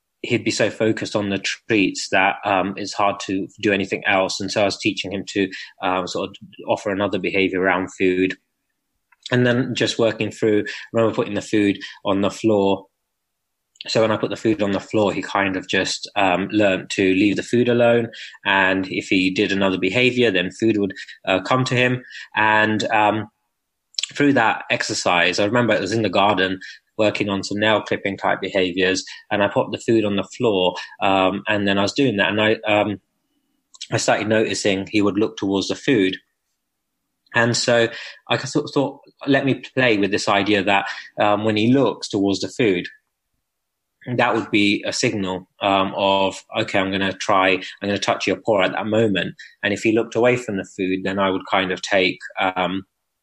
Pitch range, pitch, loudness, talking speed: 95-115 Hz, 100 Hz, -20 LUFS, 200 wpm